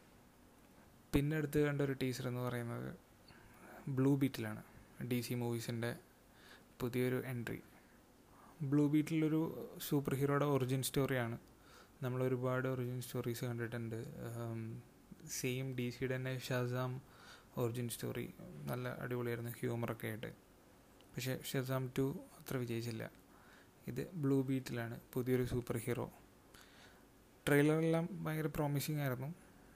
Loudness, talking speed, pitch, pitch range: -39 LUFS, 100 wpm, 130 Hz, 120-140 Hz